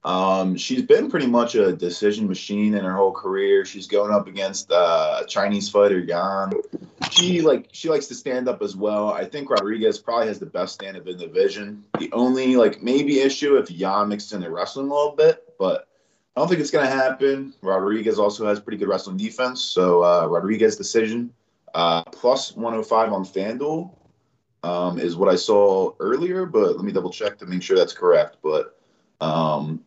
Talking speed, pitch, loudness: 195 wpm, 115 Hz, -21 LUFS